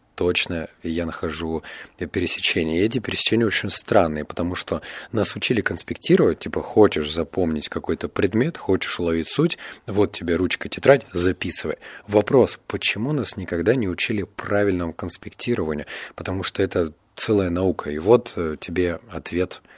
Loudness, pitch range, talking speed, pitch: -22 LUFS, 80-95 Hz, 135 wpm, 85 Hz